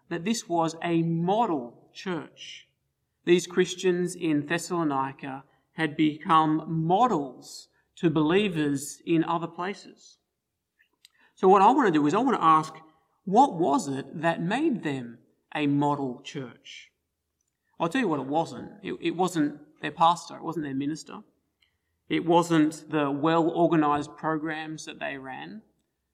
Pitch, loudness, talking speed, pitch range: 160 Hz, -26 LUFS, 140 wpm, 145-170 Hz